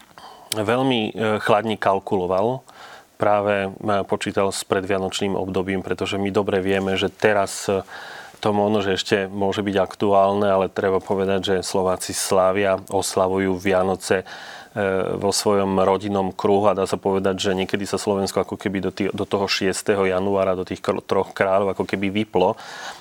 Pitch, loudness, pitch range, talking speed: 95 Hz, -21 LUFS, 95-105 Hz, 145 wpm